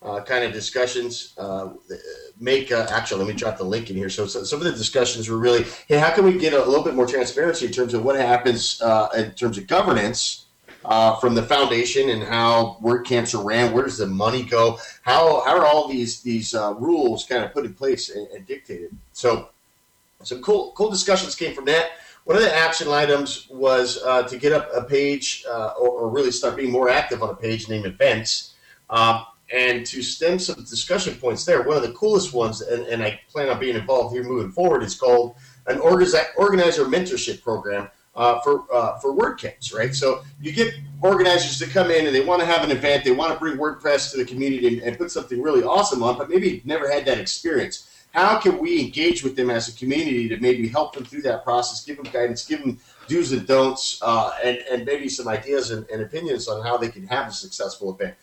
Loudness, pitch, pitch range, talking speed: -21 LUFS, 130 Hz, 120-165 Hz, 225 wpm